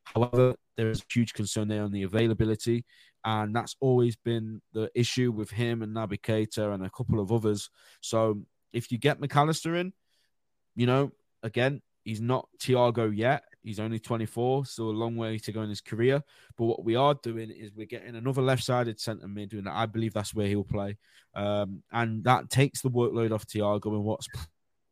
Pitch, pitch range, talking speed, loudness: 115 Hz, 105-120 Hz, 190 wpm, -29 LUFS